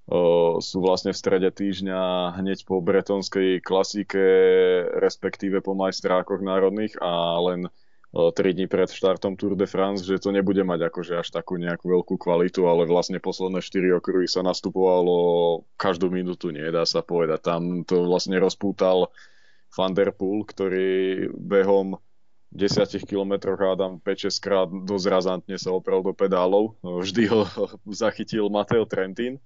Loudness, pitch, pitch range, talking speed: -23 LUFS, 95 Hz, 90-100 Hz, 145 wpm